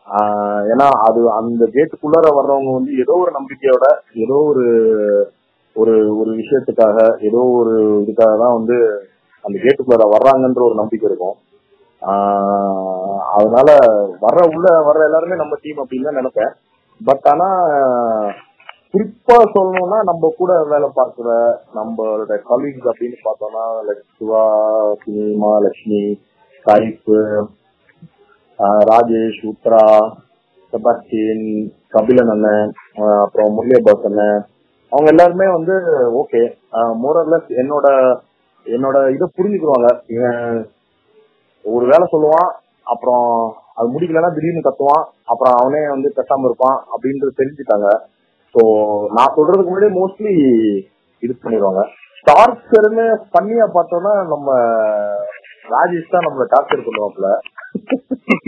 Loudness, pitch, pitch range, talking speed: -14 LUFS, 125 Hz, 110-170 Hz, 95 wpm